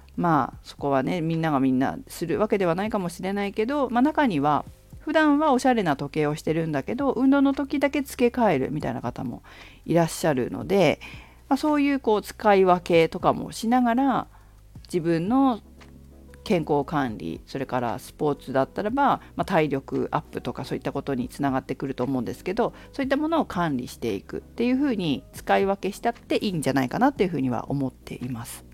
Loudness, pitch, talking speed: -24 LUFS, 165 Hz, 420 characters per minute